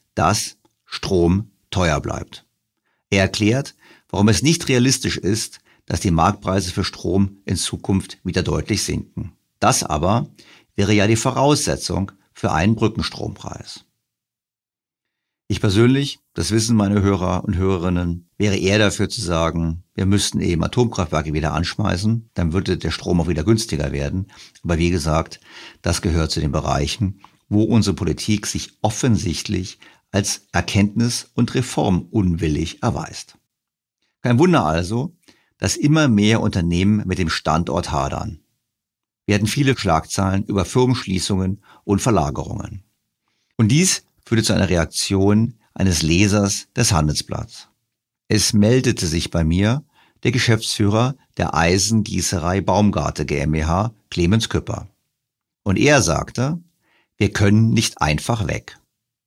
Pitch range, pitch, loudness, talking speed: 90-110 Hz, 100 Hz, -19 LUFS, 130 wpm